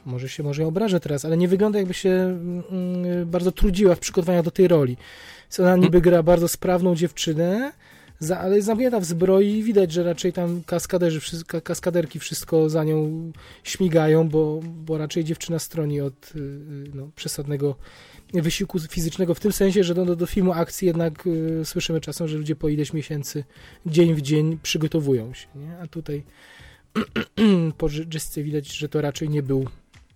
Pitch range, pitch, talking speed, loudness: 155-180 Hz, 165 Hz, 170 wpm, -22 LUFS